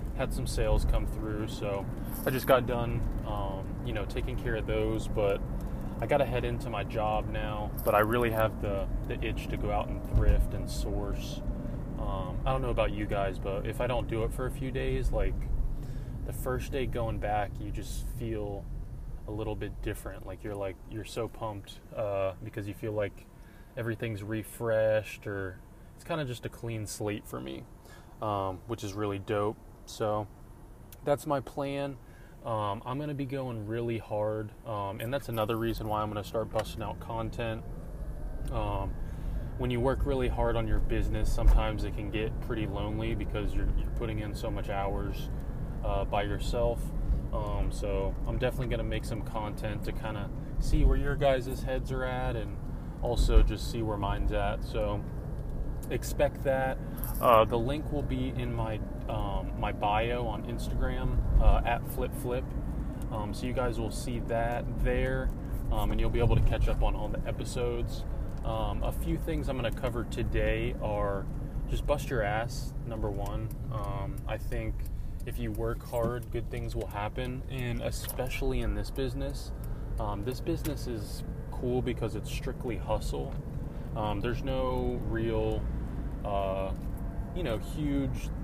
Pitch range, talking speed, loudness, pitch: 105-125 Hz, 180 wpm, -33 LUFS, 115 Hz